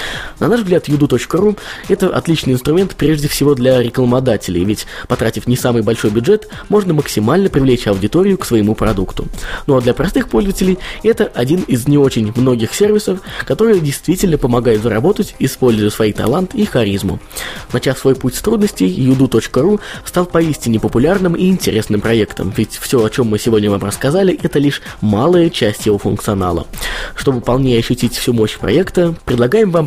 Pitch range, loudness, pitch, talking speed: 110-170 Hz, -14 LUFS, 130 Hz, 160 wpm